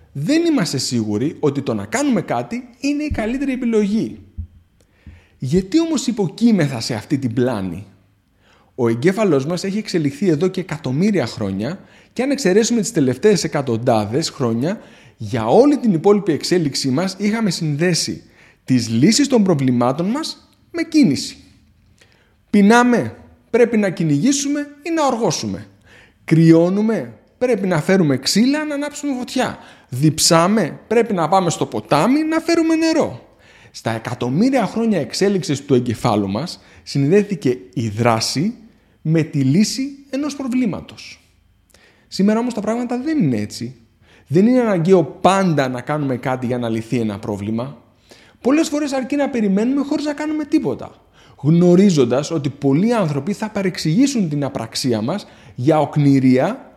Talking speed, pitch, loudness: 135 wpm, 165 Hz, -18 LUFS